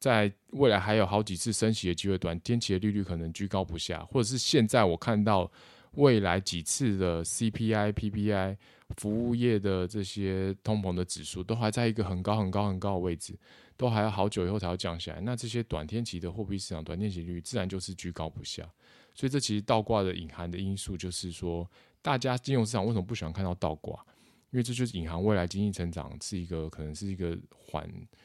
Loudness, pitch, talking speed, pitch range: -31 LUFS, 100 Hz, 340 characters per minute, 90-110 Hz